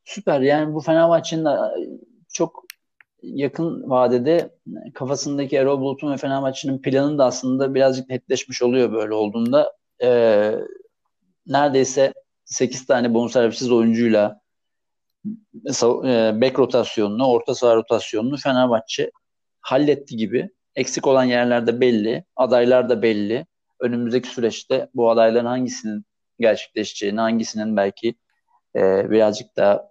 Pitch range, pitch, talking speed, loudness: 115-145 Hz, 130 Hz, 110 wpm, -20 LUFS